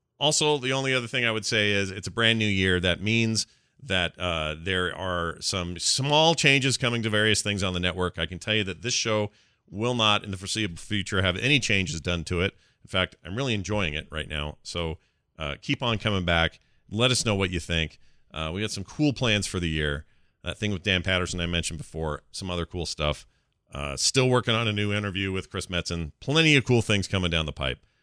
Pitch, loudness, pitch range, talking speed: 100 Hz, -25 LUFS, 85-115 Hz, 230 wpm